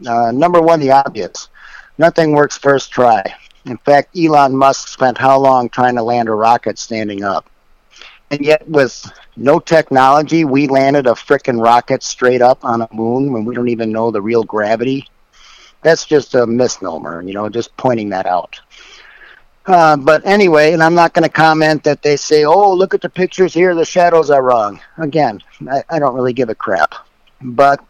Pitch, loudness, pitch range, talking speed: 135 Hz, -12 LUFS, 120-155 Hz, 185 wpm